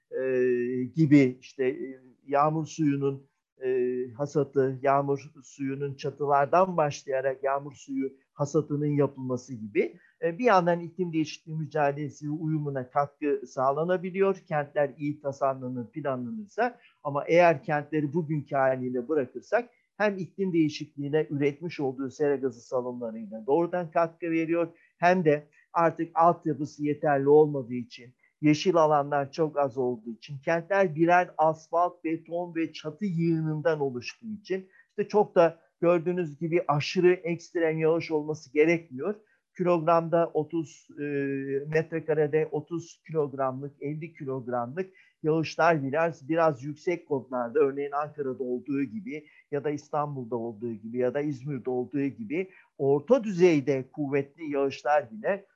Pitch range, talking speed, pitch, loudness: 135-165 Hz, 120 wpm, 150 Hz, -28 LUFS